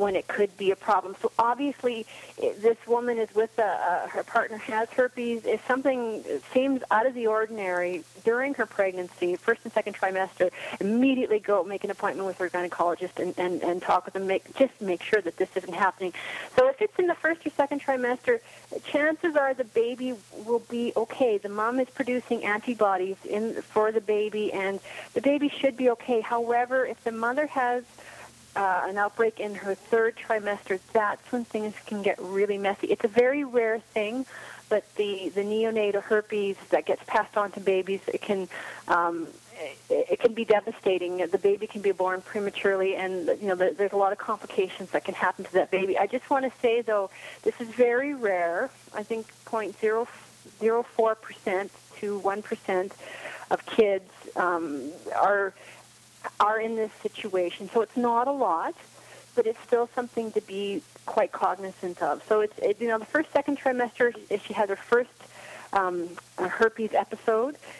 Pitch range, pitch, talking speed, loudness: 195-245 Hz, 220 Hz, 180 wpm, -27 LUFS